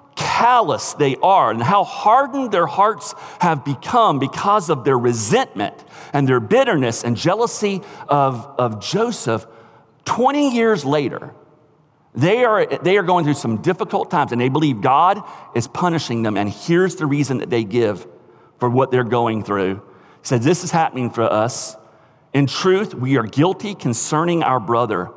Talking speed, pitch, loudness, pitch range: 165 wpm, 140 Hz, -18 LUFS, 120-175 Hz